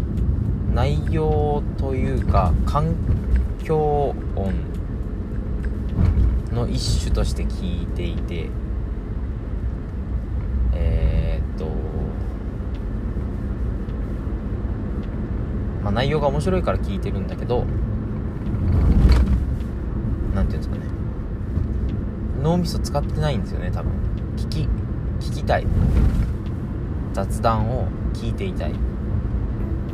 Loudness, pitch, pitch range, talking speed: -24 LUFS, 100 Hz, 85-105 Hz, 165 characters per minute